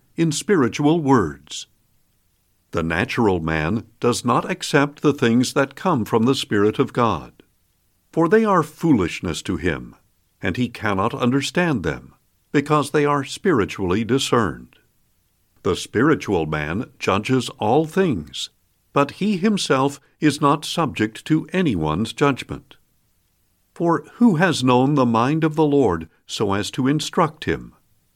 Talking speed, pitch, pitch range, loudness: 135 wpm, 130 Hz, 100-150 Hz, -20 LUFS